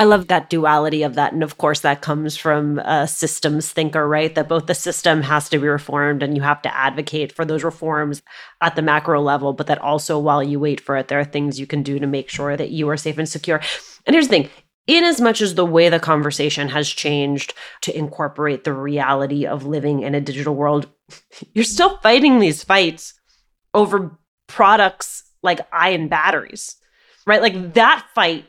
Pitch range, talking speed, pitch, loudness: 145-165 Hz, 205 wpm, 150 Hz, -18 LUFS